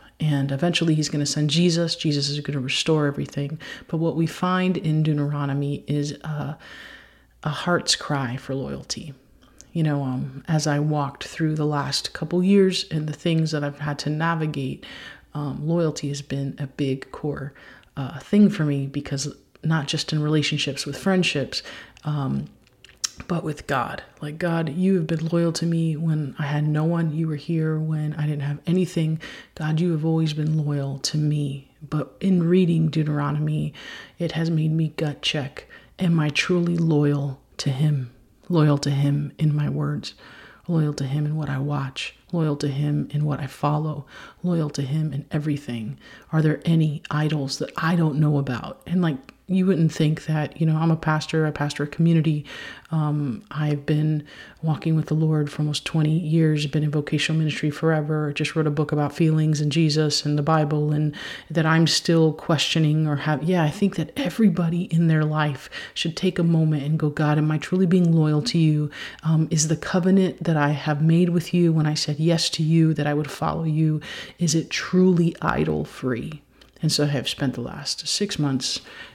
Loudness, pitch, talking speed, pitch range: -23 LUFS, 155 Hz, 190 wpm, 145-165 Hz